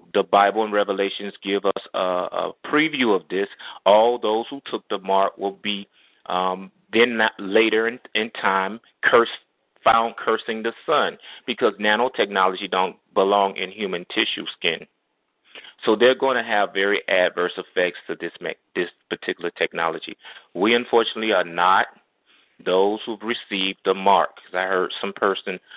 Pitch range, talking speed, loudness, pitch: 95-115 Hz, 155 wpm, -22 LUFS, 100 Hz